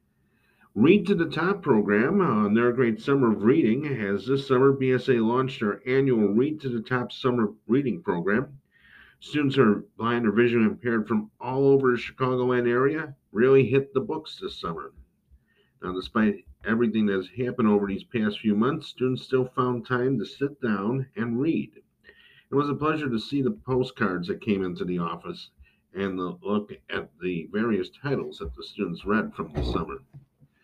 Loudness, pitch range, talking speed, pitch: -25 LUFS, 105-135 Hz, 180 wpm, 125 Hz